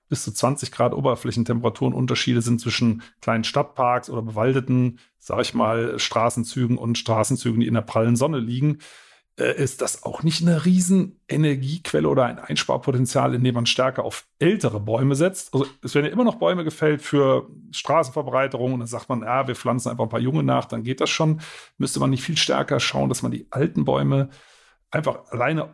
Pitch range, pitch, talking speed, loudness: 115-145 Hz, 125 Hz, 185 wpm, -22 LUFS